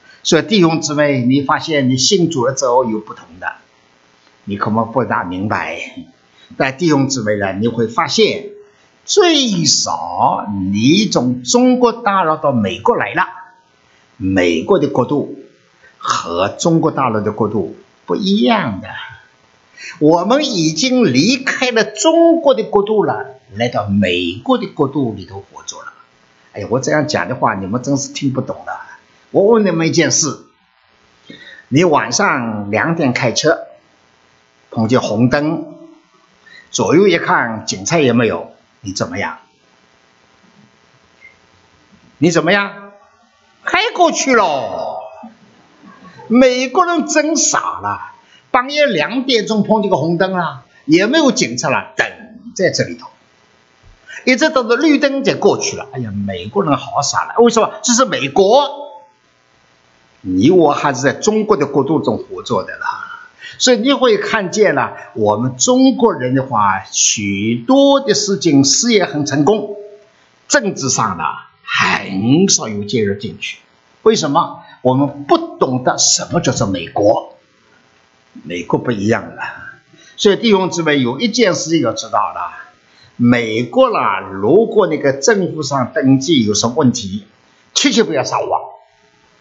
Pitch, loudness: 150 Hz, -14 LUFS